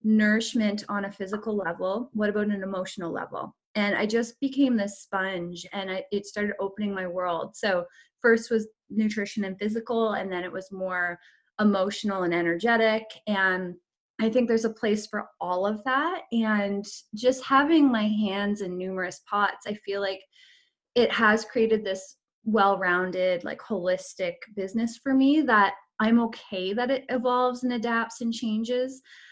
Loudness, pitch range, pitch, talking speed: -26 LUFS, 190-230 Hz, 210 Hz, 160 wpm